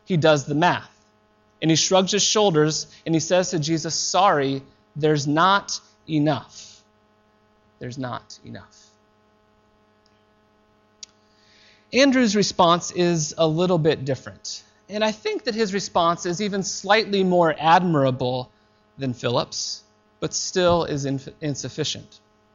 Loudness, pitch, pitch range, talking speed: -21 LUFS, 135 Hz, 105-175 Hz, 120 wpm